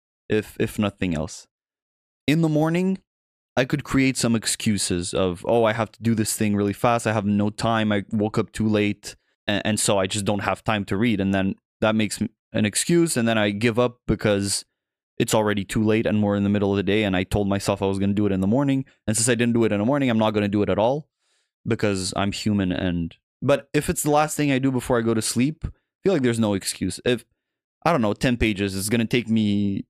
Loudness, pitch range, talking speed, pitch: -22 LUFS, 100-120 Hz, 255 wpm, 110 Hz